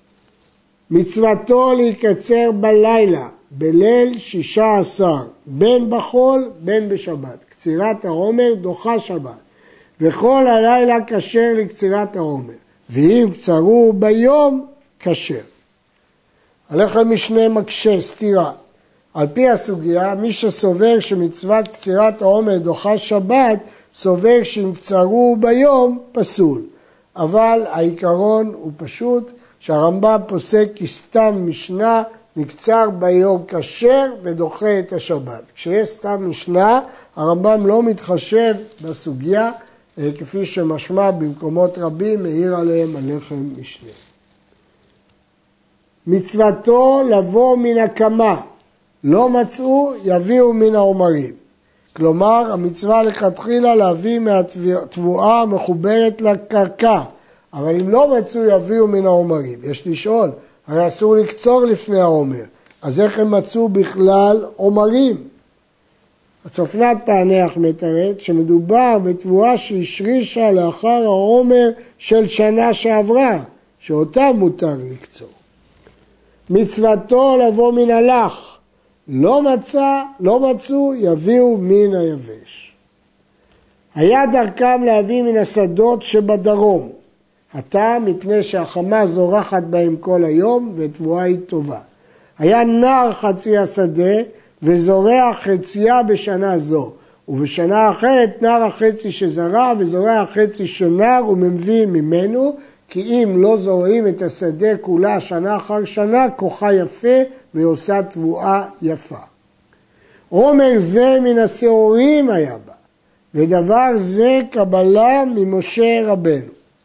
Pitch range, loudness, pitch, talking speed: 175-230 Hz, -15 LUFS, 205 Hz, 100 wpm